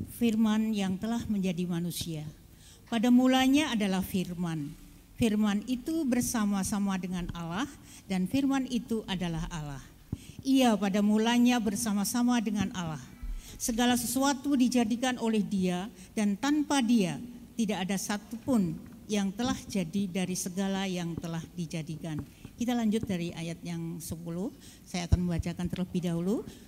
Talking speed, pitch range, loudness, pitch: 125 wpm, 180-240 Hz, -30 LUFS, 205 Hz